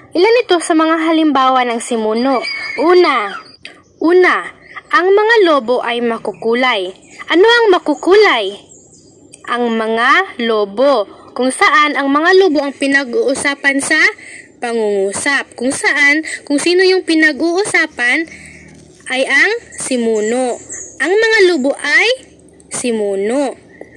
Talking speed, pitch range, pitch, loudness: 110 wpm, 250-370 Hz, 300 Hz, -12 LUFS